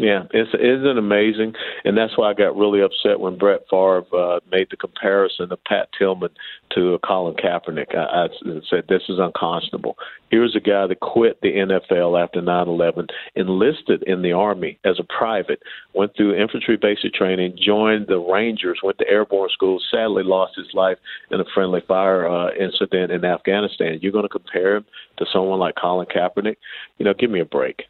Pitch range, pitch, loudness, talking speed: 90-105 Hz, 95 Hz, -19 LUFS, 190 wpm